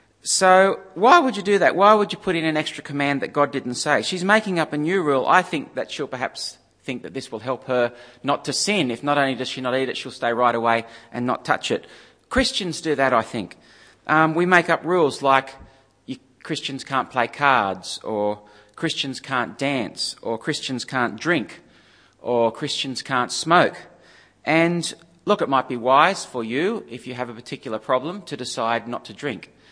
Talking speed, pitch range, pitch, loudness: 200 wpm, 120-165 Hz, 135 Hz, -21 LUFS